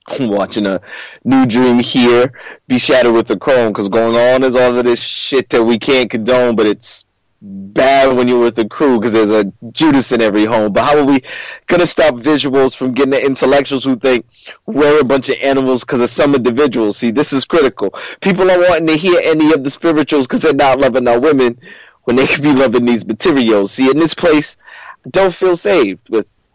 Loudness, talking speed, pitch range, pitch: -12 LUFS, 210 wpm, 120-150 Hz, 130 Hz